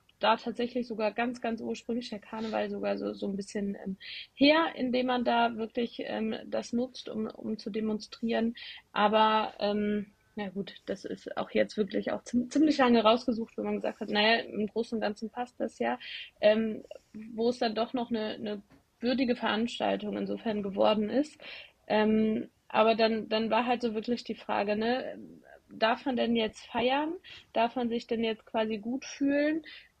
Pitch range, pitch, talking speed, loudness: 215-245 Hz, 225 Hz, 175 wpm, -30 LUFS